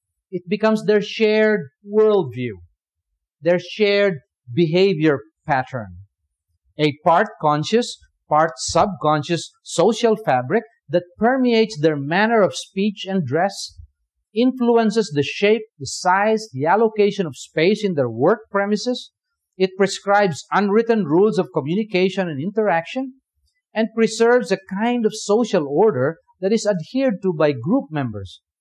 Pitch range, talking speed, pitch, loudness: 150-220 Hz, 125 wpm, 195 Hz, -19 LUFS